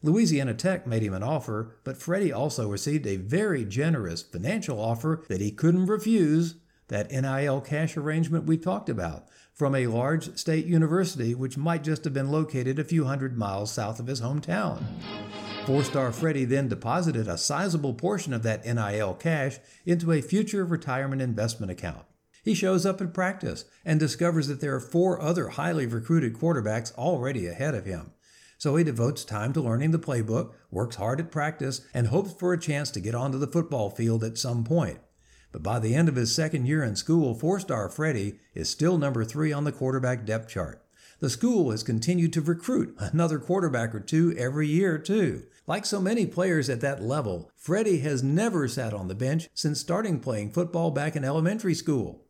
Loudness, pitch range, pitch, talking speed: -27 LUFS, 115-165 Hz, 145 Hz, 190 wpm